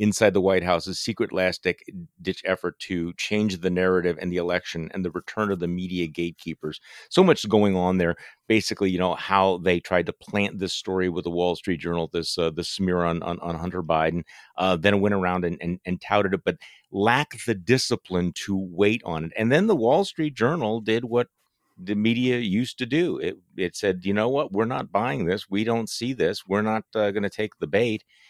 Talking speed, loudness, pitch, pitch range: 215 wpm, -24 LUFS, 95 Hz, 90-110 Hz